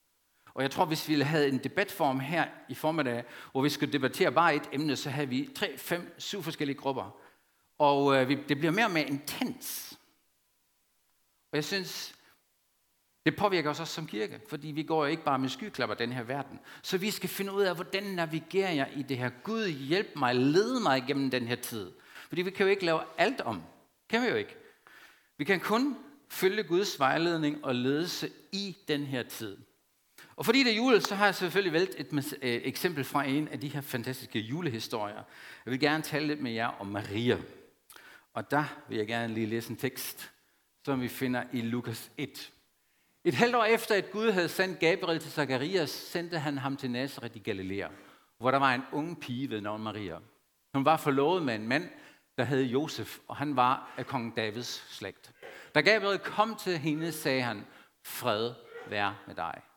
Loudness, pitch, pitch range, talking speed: -31 LUFS, 145 Hz, 130-175 Hz, 195 wpm